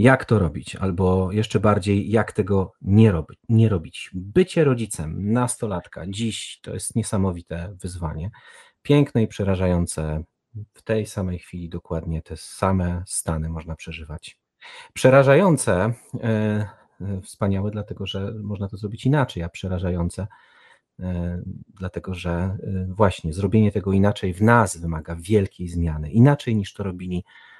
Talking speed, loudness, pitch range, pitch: 130 wpm, -22 LUFS, 90-110 Hz, 100 Hz